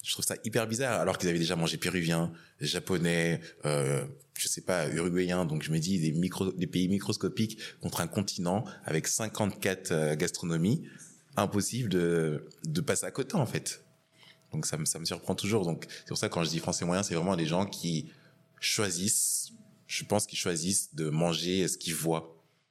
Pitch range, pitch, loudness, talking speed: 80-100 Hz, 90 Hz, -31 LUFS, 195 wpm